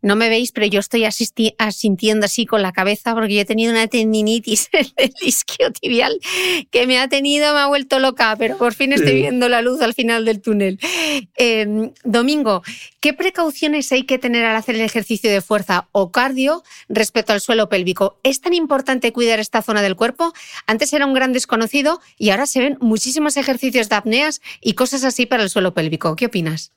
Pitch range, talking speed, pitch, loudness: 215-270 Hz, 195 wpm, 235 Hz, -17 LUFS